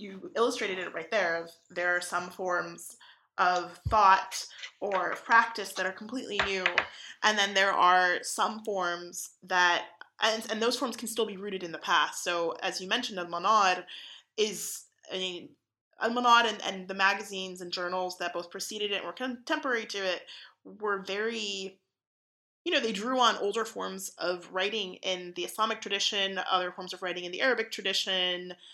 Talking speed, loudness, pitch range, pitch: 175 wpm, -29 LUFS, 180-220 Hz, 190 Hz